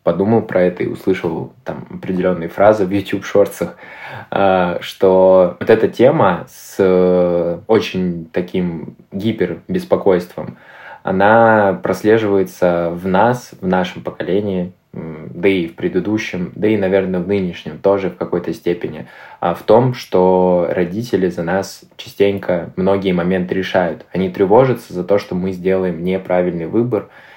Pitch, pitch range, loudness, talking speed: 95 Hz, 90-100 Hz, -16 LUFS, 130 wpm